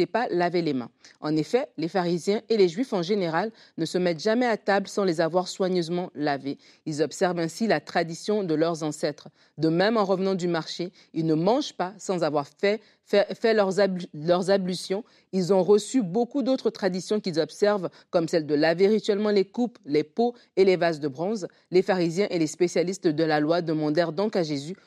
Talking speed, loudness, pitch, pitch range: 200 wpm, -25 LUFS, 185 Hz, 165-205 Hz